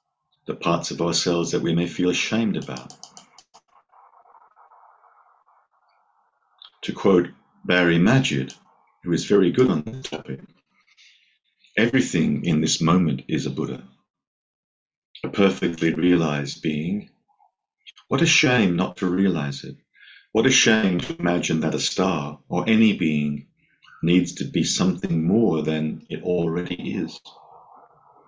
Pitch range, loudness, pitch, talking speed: 75-90 Hz, -22 LUFS, 85 Hz, 125 wpm